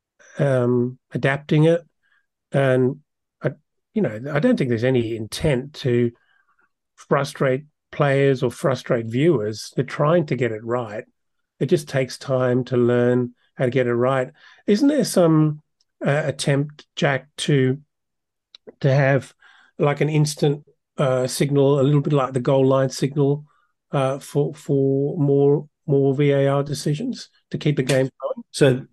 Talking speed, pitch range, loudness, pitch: 145 wpm, 130-150 Hz, -21 LUFS, 140 Hz